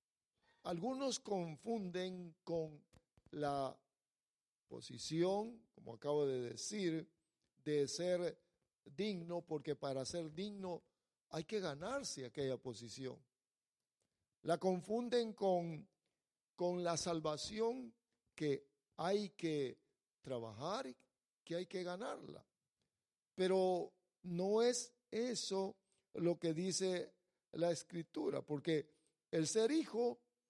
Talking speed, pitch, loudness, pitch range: 95 wpm, 175 Hz, -42 LUFS, 150-195 Hz